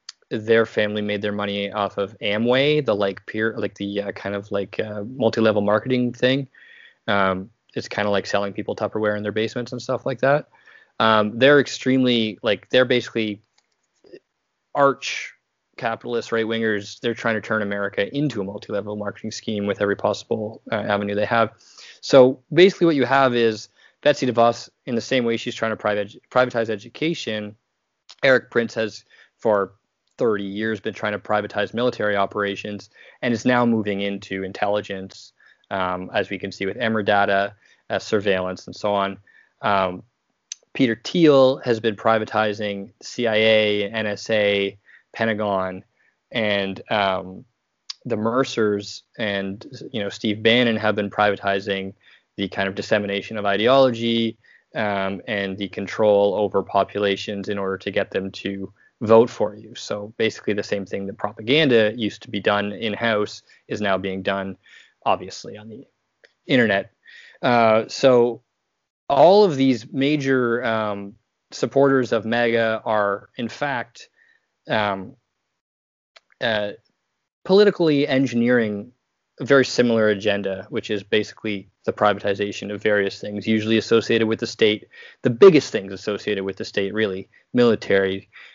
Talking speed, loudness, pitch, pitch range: 145 wpm, -21 LUFS, 105 Hz, 100-120 Hz